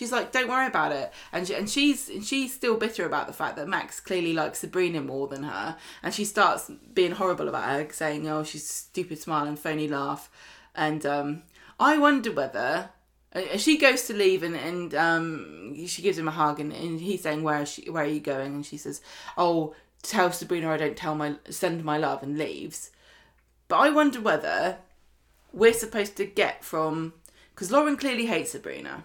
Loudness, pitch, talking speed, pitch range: -27 LUFS, 170 Hz, 200 wpm, 150-205 Hz